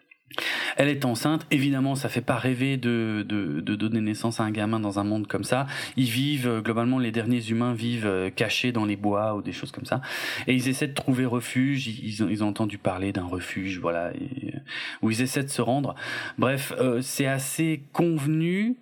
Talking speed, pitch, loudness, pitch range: 205 wpm, 120 Hz, -26 LUFS, 105-135 Hz